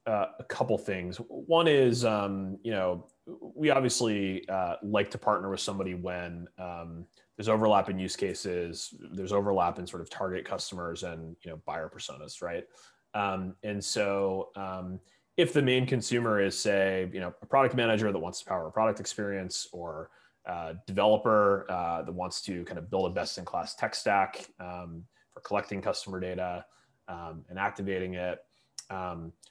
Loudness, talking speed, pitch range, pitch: -30 LUFS, 175 wpm, 90-110 Hz, 95 Hz